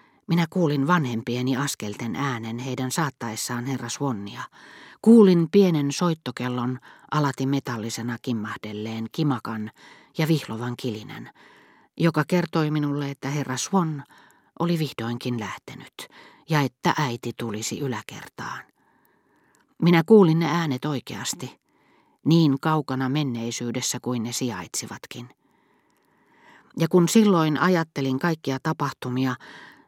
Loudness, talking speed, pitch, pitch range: -24 LUFS, 100 wpm, 135 Hz, 120-160 Hz